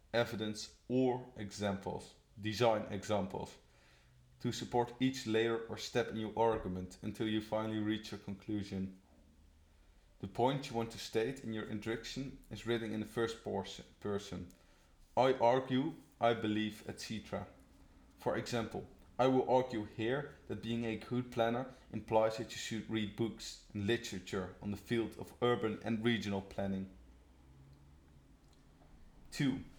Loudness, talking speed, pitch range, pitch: -38 LUFS, 135 wpm, 95-115 Hz, 110 Hz